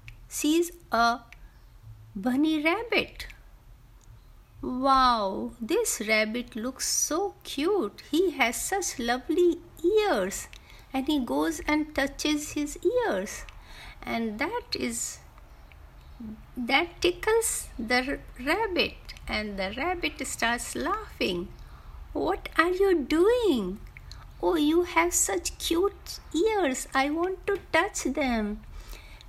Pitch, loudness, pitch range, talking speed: 300 Hz, -27 LUFS, 240-355 Hz, 100 wpm